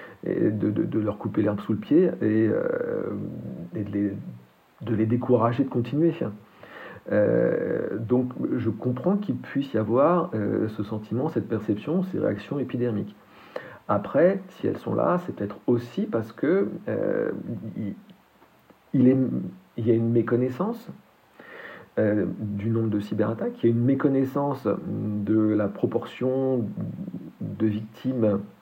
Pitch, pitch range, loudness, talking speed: 115 Hz, 105-130 Hz, -26 LUFS, 145 wpm